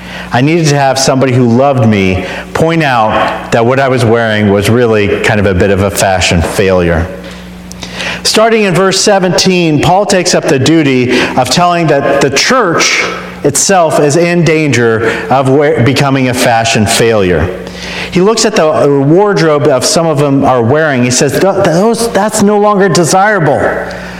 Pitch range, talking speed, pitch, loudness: 115-175 Hz, 170 wpm, 140 Hz, -8 LUFS